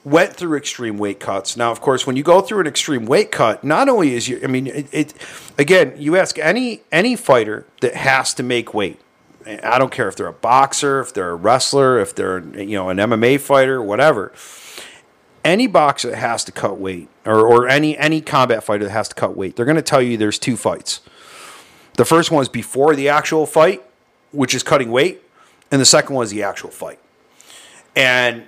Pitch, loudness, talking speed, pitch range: 130 Hz, -16 LUFS, 215 wpm, 115-145 Hz